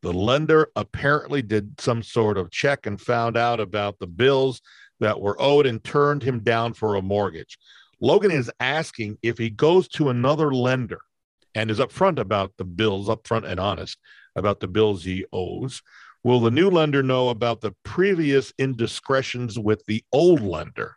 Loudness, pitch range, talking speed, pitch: -22 LUFS, 105-135 Hz, 170 wpm, 115 Hz